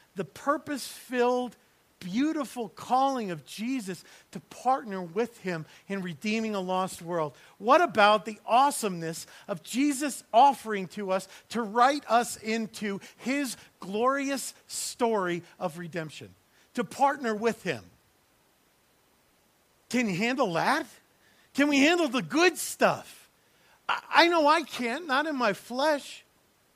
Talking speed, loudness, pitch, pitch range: 125 wpm, -28 LUFS, 230 Hz, 190-275 Hz